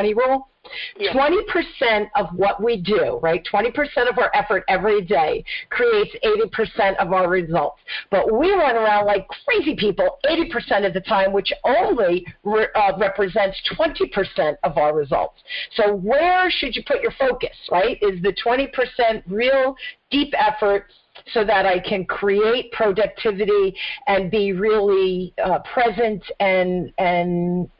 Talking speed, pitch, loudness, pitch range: 155 wpm, 220 Hz, -20 LUFS, 195-285 Hz